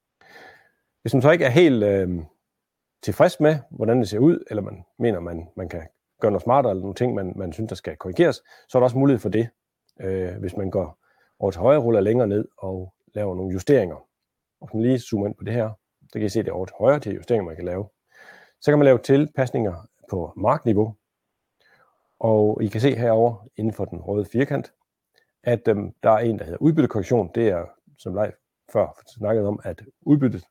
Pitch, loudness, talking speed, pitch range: 110 Hz, -22 LUFS, 220 wpm, 95-125 Hz